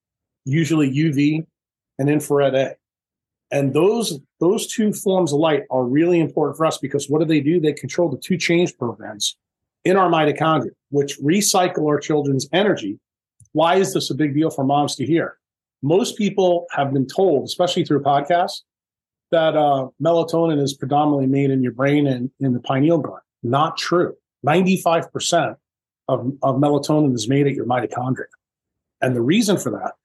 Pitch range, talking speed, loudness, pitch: 135-165 Hz, 170 wpm, -19 LUFS, 145 Hz